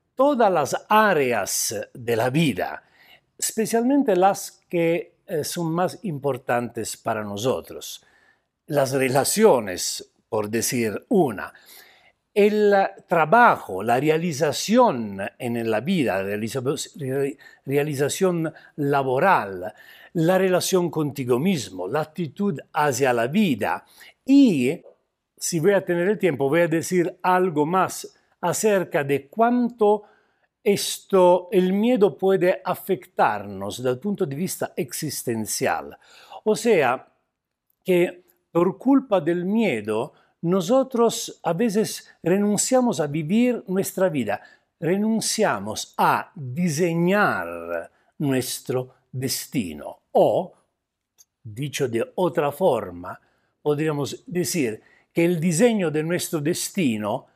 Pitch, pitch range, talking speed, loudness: 175 Hz, 140-200 Hz, 100 wpm, -22 LUFS